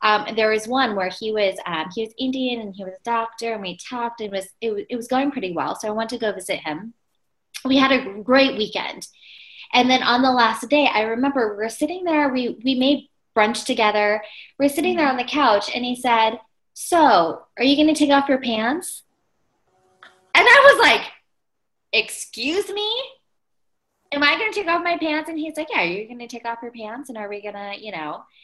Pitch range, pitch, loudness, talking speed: 215-285 Hz, 240 Hz, -20 LUFS, 230 wpm